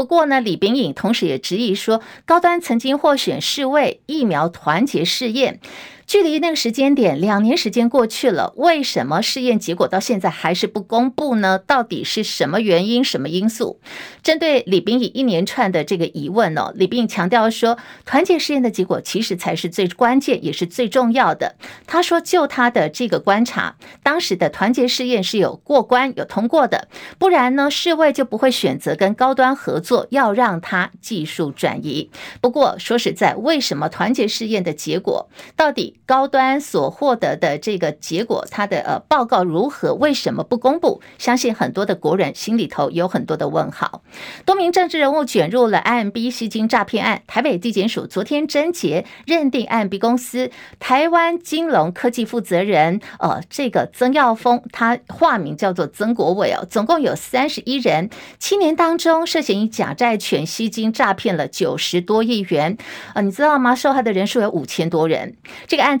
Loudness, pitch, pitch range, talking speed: -18 LUFS, 240 Hz, 200-275 Hz, 285 characters per minute